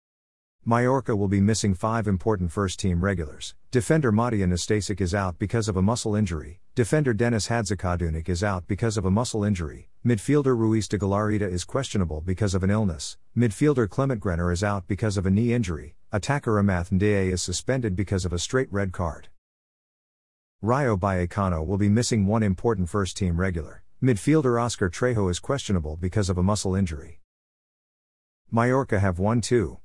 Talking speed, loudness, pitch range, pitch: 165 wpm, -25 LUFS, 90-115 Hz, 100 Hz